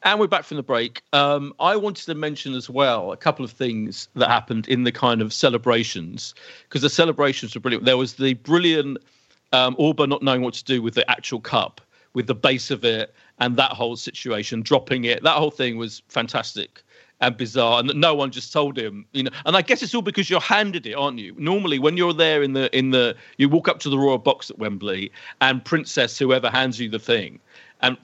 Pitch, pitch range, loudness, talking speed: 130 Hz, 120-150 Hz, -21 LUFS, 230 wpm